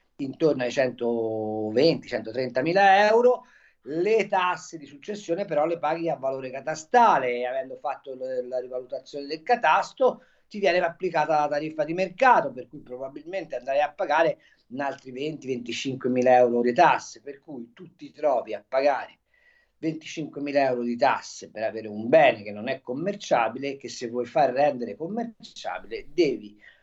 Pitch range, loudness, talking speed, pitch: 125-180 Hz, -25 LUFS, 155 wpm, 145 Hz